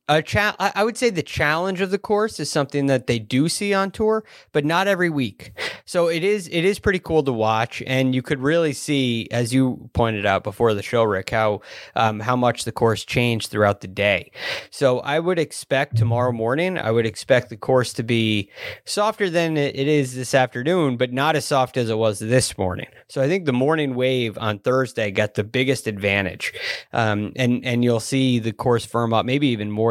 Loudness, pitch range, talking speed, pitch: -21 LUFS, 115-155 Hz, 210 wpm, 130 Hz